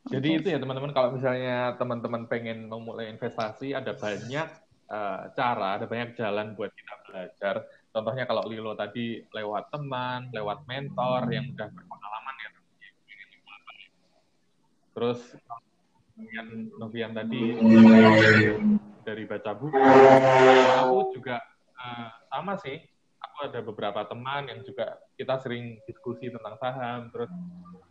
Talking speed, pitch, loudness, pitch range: 125 wpm, 120 Hz, -24 LUFS, 110-130 Hz